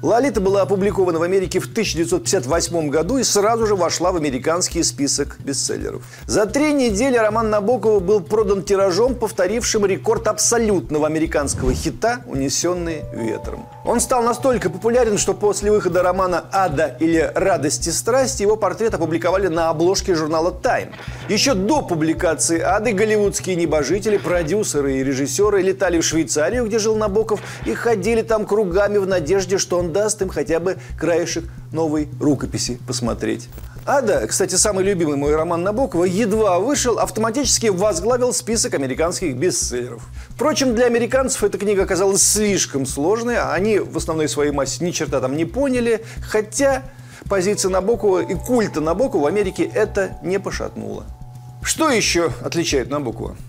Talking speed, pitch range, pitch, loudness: 145 wpm, 155-215 Hz, 185 Hz, -19 LUFS